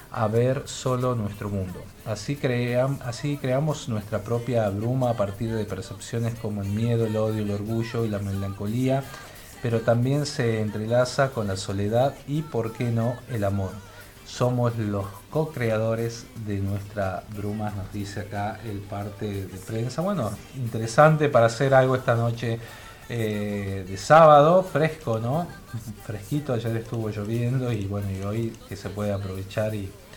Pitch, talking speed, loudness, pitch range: 115 Hz, 155 wpm, -25 LUFS, 105-125 Hz